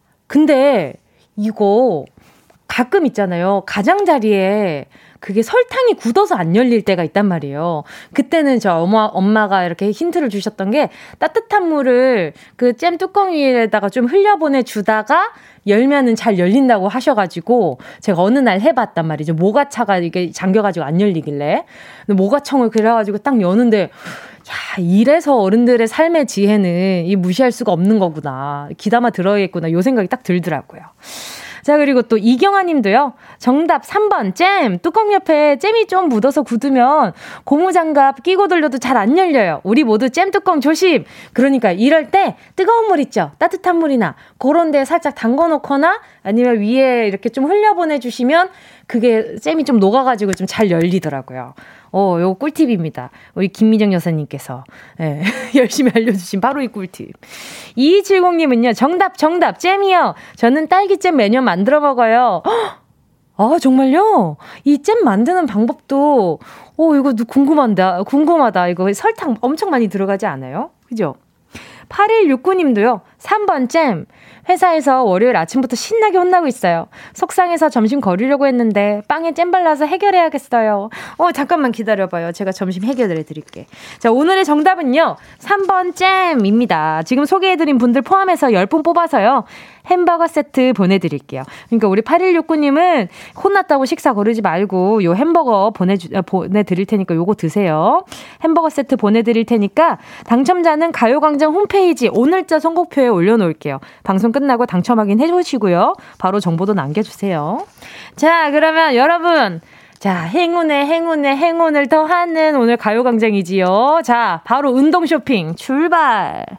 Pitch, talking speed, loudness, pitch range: 250 Hz, 325 characters per minute, -14 LUFS, 200-325 Hz